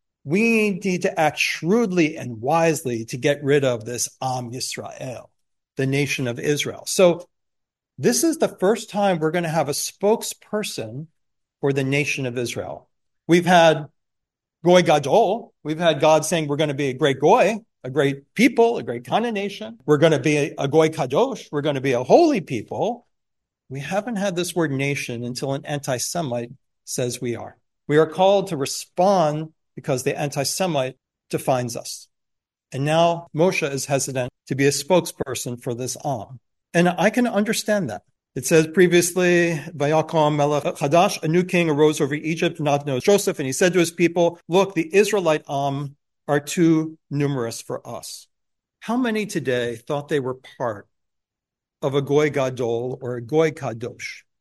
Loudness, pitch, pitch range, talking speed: -21 LUFS, 150 Hz, 135-175 Hz, 170 wpm